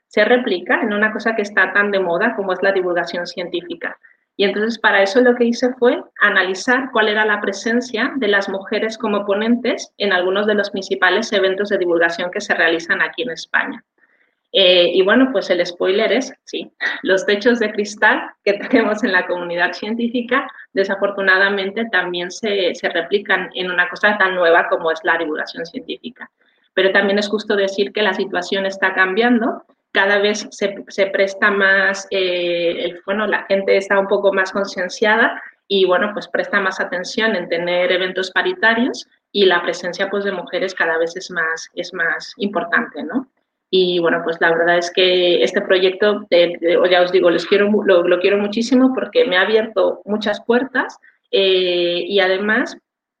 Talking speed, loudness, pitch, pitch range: 180 wpm, -17 LUFS, 195 Hz, 180-215 Hz